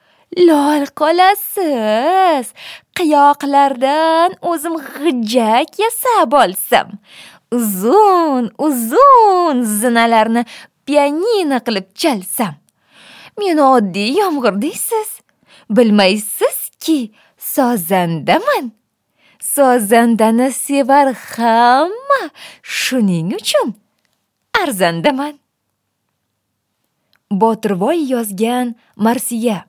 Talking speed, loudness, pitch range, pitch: 55 wpm, -14 LUFS, 225-320 Hz, 260 Hz